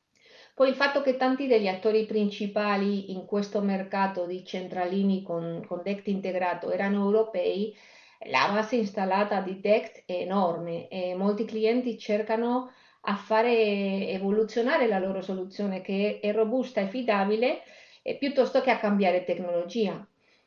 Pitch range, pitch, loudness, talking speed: 190-220 Hz, 205 Hz, -27 LUFS, 140 wpm